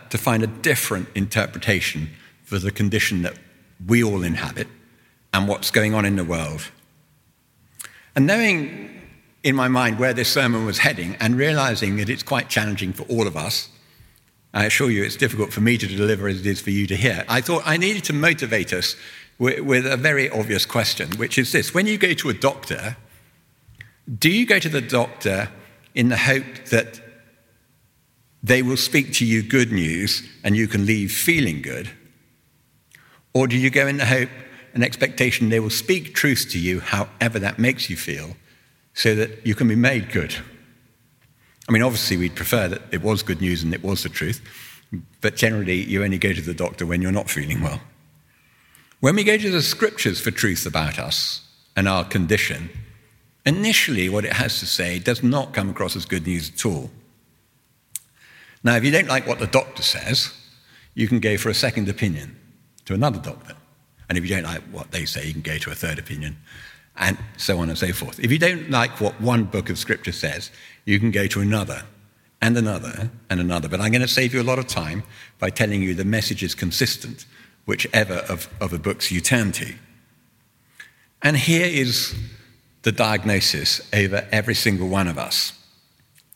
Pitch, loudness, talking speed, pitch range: 110 Hz, -21 LUFS, 190 wpm, 100-130 Hz